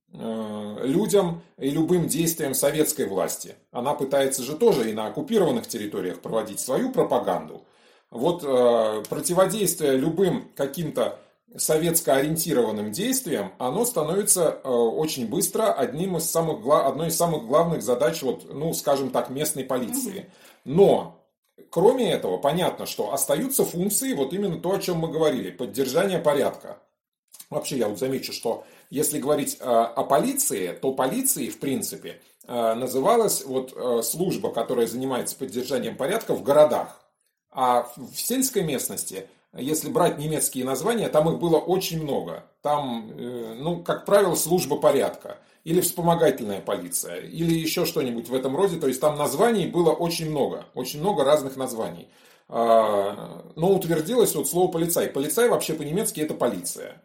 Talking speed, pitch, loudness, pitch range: 135 wpm, 155 Hz, -24 LUFS, 130-180 Hz